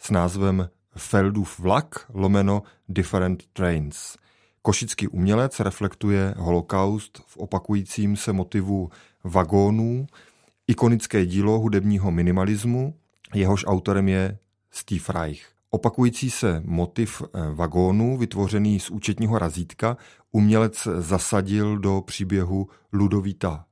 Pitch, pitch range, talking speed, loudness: 100 Hz, 95-105 Hz, 95 wpm, -23 LUFS